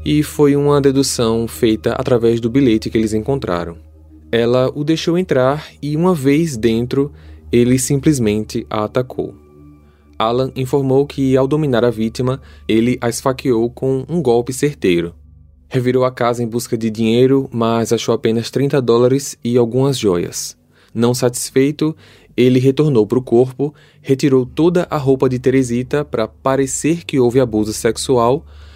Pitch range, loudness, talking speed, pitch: 115-140 Hz, -16 LUFS, 150 wpm, 125 Hz